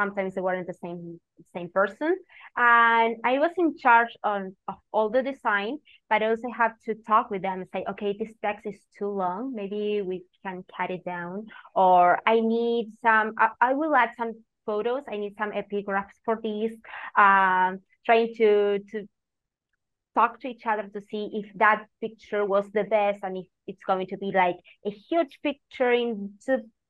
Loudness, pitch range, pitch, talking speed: -25 LUFS, 195-230 Hz, 210 Hz, 185 wpm